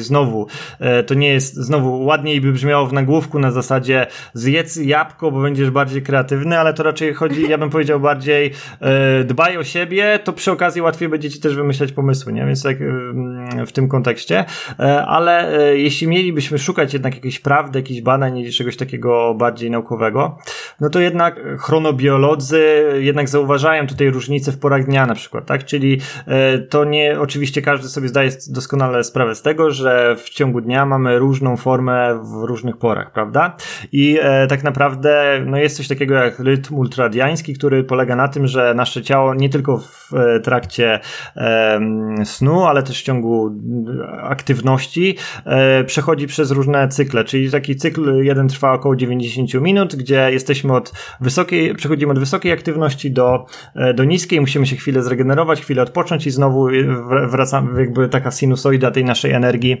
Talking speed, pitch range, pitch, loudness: 160 wpm, 130-150 Hz, 135 Hz, -16 LUFS